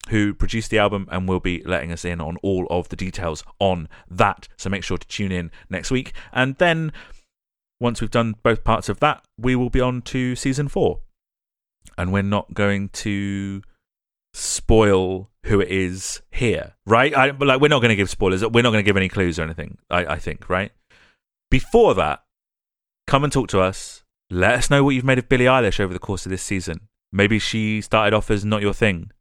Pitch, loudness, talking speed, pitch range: 105 Hz, -20 LUFS, 210 wpm, 95-120 Hz